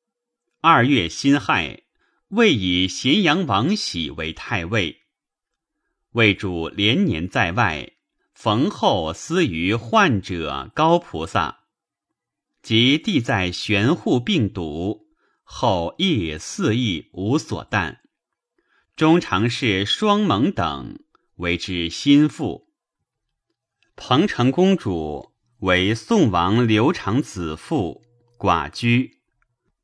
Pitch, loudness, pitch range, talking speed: 110 Hz, -20 LUFS, 90-140 Hz, 130 characters per minute